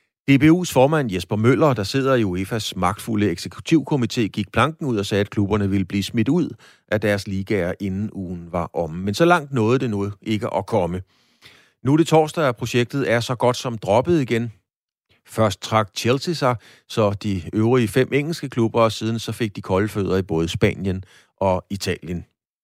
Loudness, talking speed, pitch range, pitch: -21 LUFS, 190 wpm, 100-125 Hz, 110 Hz